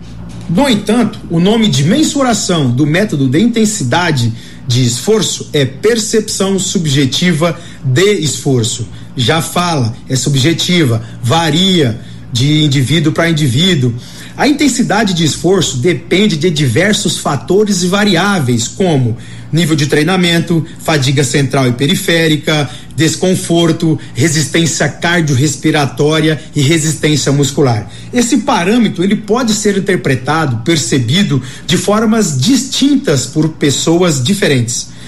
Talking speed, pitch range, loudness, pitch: 110 wpm, 140-190 Hz, -12 LUFS, 160 Hz